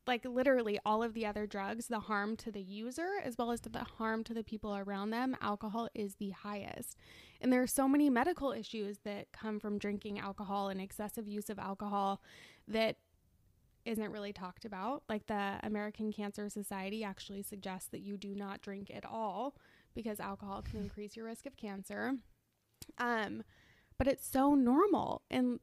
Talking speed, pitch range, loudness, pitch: 180 wpm, 200-235 Hz, -38 LUFS, 210 Hz